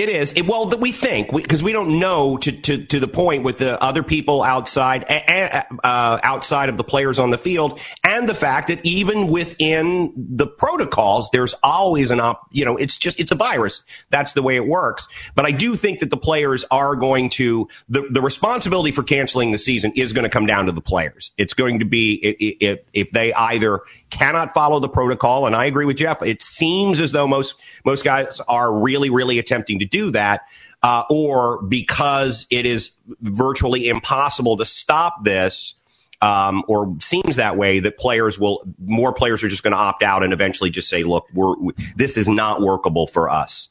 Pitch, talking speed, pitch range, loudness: 130 Hz, 210 wpm, 110-150 Hz, -18 LUFS